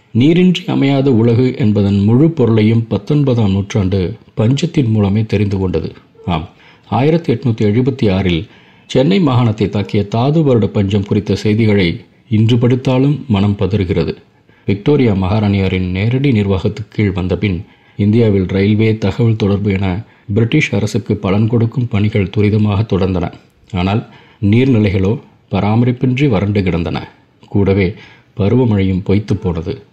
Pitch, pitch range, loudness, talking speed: 105 Hz, 100-120 Hz, -14 LUFS, 110 wpm